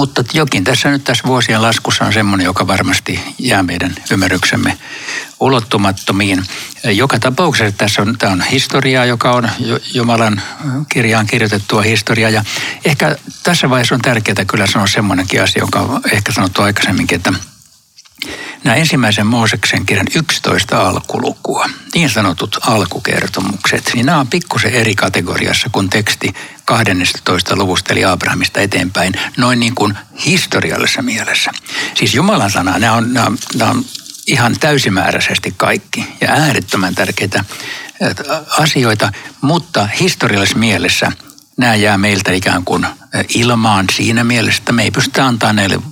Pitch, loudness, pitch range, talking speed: 115 Hz, -12 LUFS, 100-125 Hz, 130 wpm